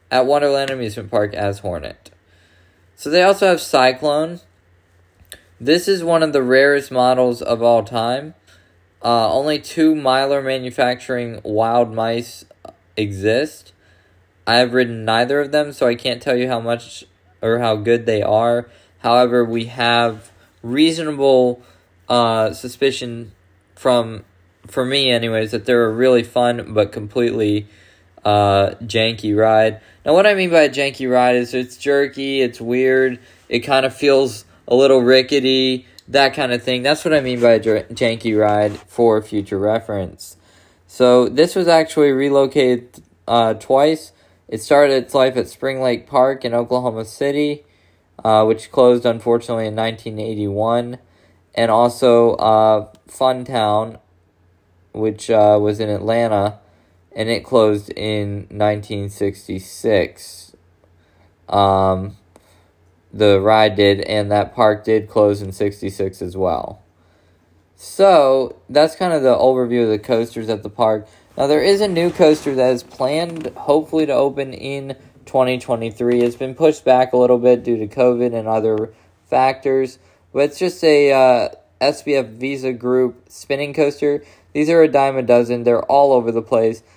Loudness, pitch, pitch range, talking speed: -17 LUFS, 115 Hz, 105-130 Hz, 150 wpm